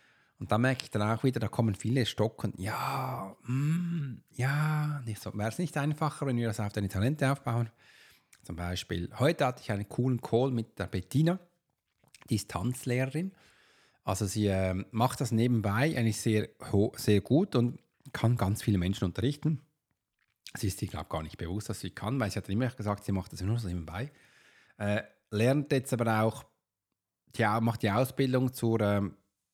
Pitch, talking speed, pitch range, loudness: 115 Hz, 175 wpm, 105-135 Hz, -31 LUFS